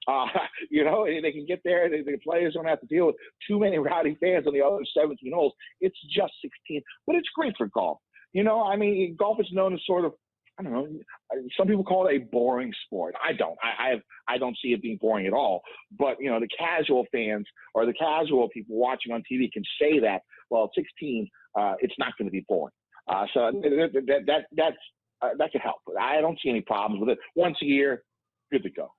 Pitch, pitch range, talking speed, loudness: 155 Hz, 130-190 Hz, 235 wpm, -27 LUFS